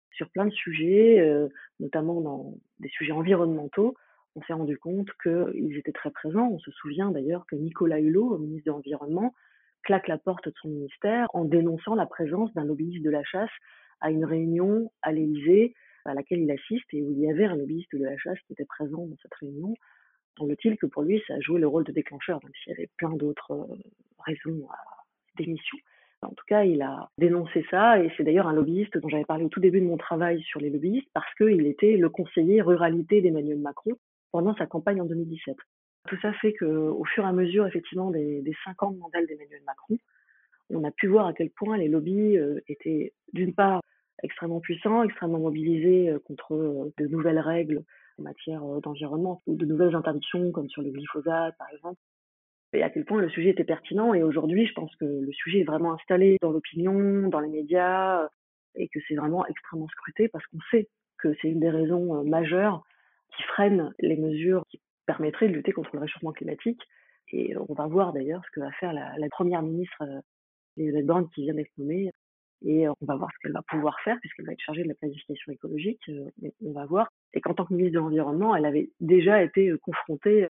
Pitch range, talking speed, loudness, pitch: 150-190 Hz, 210 wpm, -27 LUFS, 165 Hz